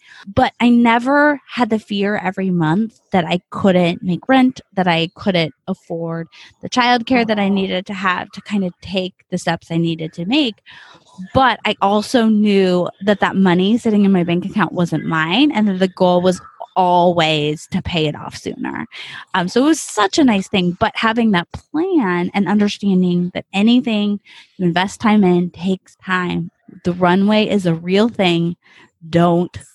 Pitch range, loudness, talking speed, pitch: 175-215 Hz, -17 LUFS, 180 wpm, 190 Hz